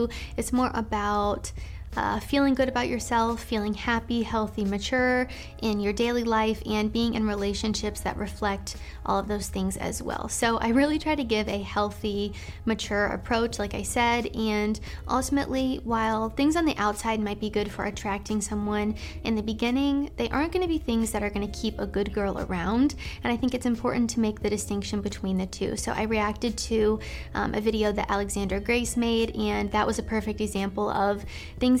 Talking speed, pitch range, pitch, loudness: 195 wpm, 205-235 Hz, 220 Hz, -27 LUFS